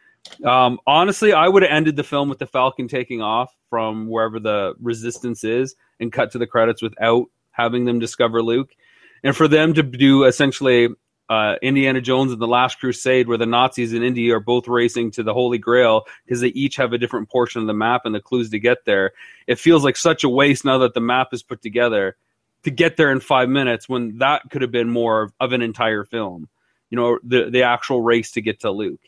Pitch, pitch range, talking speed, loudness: 125 Hz, 115-130 Hz, 225 wpm, -18 LUFS